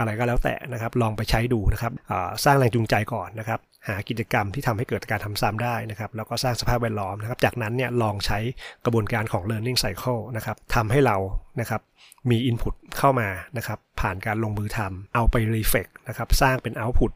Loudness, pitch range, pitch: -25 LUFS, 110-125 Hz, 115 Hz